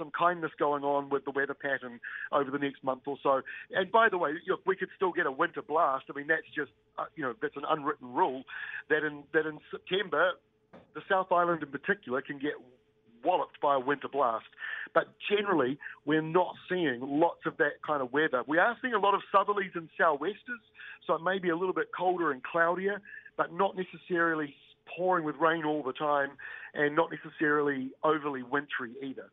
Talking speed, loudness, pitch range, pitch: 205 wpm, -31 LUFS, 145-180 Hz, 155 Hz